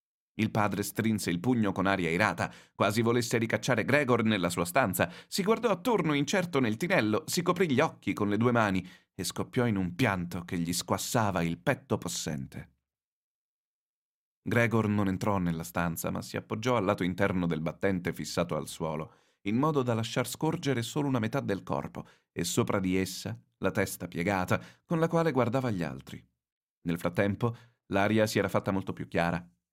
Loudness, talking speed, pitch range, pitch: -30 LUFS, 180 wpm, 90-120 Hz, 105 Hz